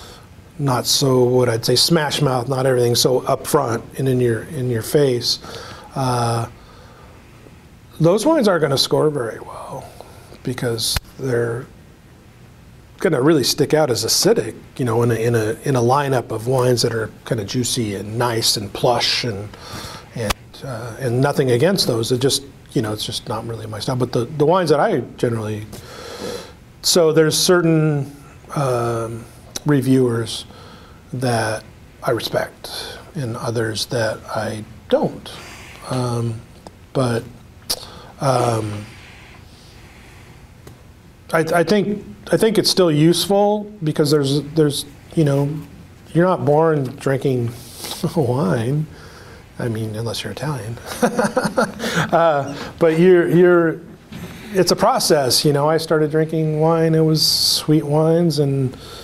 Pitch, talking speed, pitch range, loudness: 125 Hz, 140 wpm, 115-155 Hz, -18 LUFS